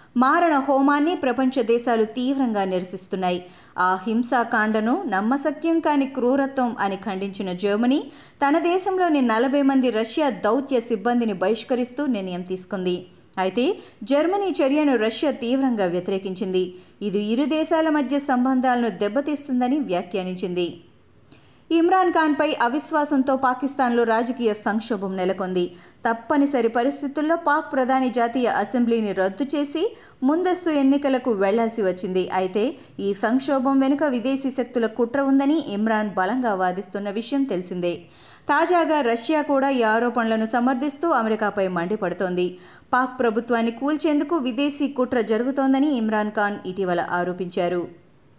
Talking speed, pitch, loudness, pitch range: 110 wpm, 245 Hz, -22 LUFS, 205-280 Hz